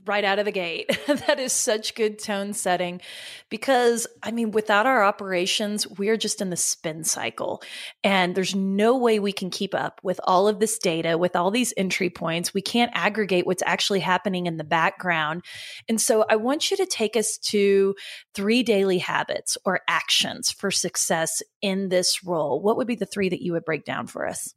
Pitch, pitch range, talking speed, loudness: 200 Hz, 180-220 Hz, 200 wpm, -23 LUFS